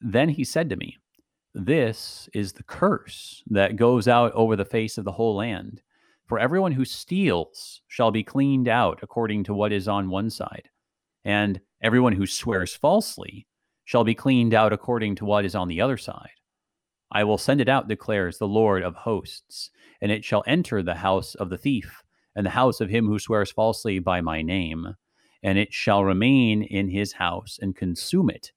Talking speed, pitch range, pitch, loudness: 190 wpm, 100-120 Hz, 105 Hz, -23 LUFS